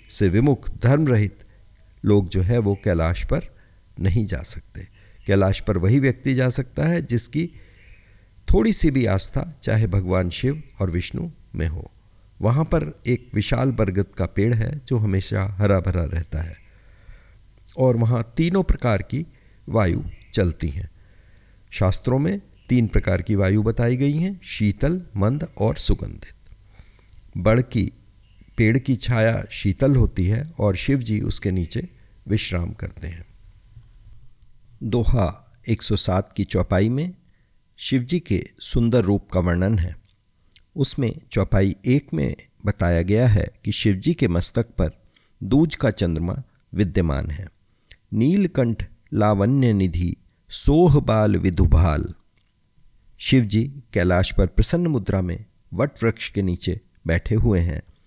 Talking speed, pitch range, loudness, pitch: 135 wpm, 95-120 Hz, -21 LUFS, 105 Hz